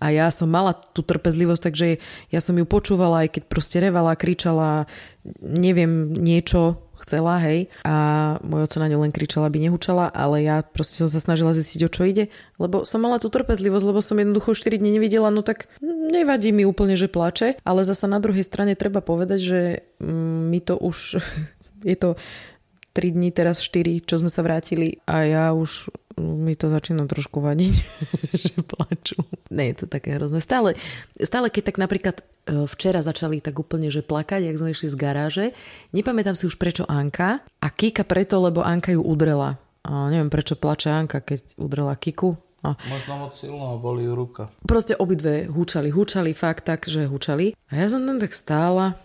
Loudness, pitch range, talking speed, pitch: -22 LUFS, 155-190 Hz, 180 wpm, 170 Hz